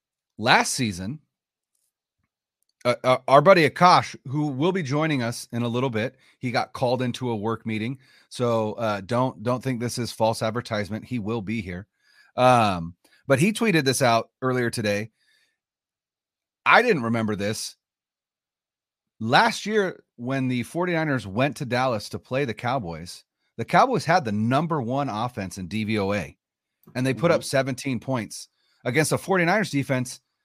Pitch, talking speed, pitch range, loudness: 125 Hz, 155 wpm, 110-135 Hz, -23 LUFS